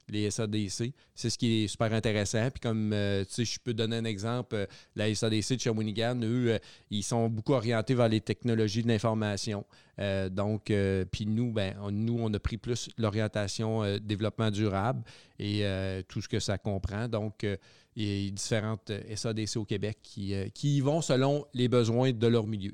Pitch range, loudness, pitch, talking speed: 105-115 Hz, -31 LUFS, 110 Hz, 205 wpm